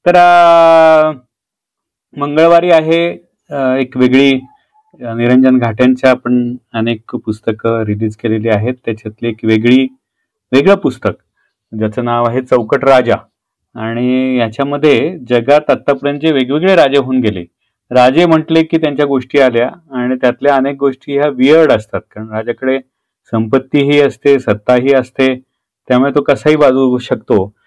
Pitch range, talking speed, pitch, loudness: 120-145 Hz, 120 wpm, 130 Hz, -11 LUFS